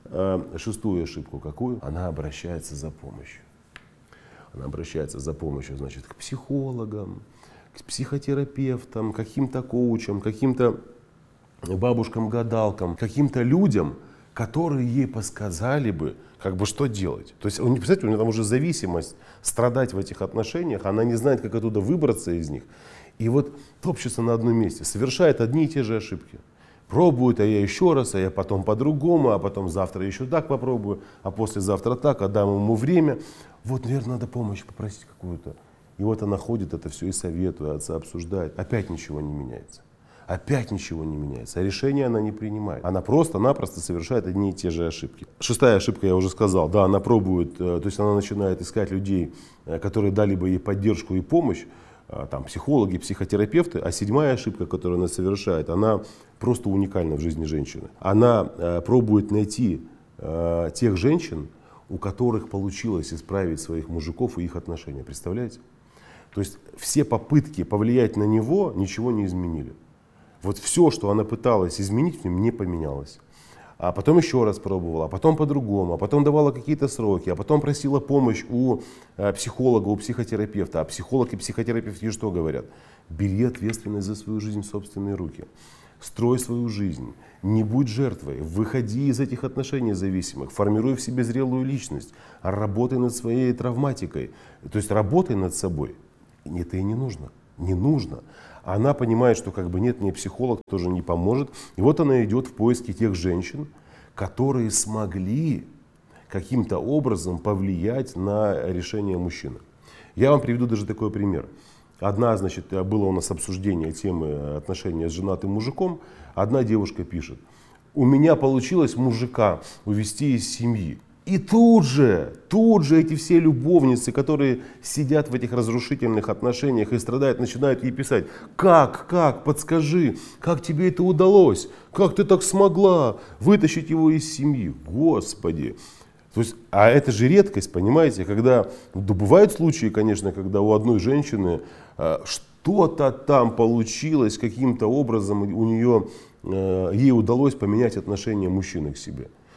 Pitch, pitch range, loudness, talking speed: 110 Hz, 95-130 Hz, -23 LUFS, 155 wpm